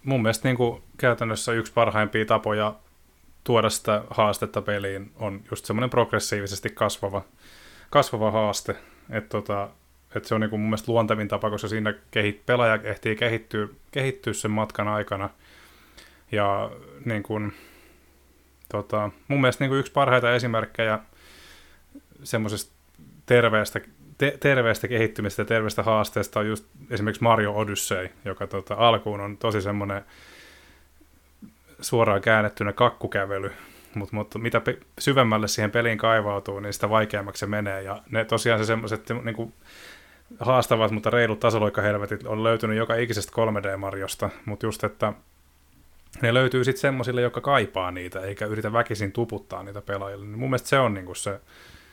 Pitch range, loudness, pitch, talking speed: 100-115 Hz, -25 LUFS, 110 Hz, 140 wpm